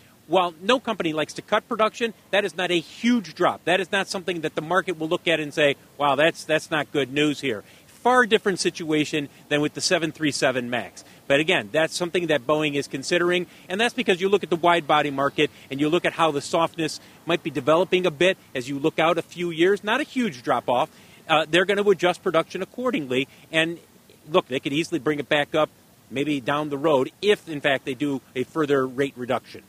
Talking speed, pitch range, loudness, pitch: 225 wpm, 150-185 Hz, -23 LUFS, 160 Hz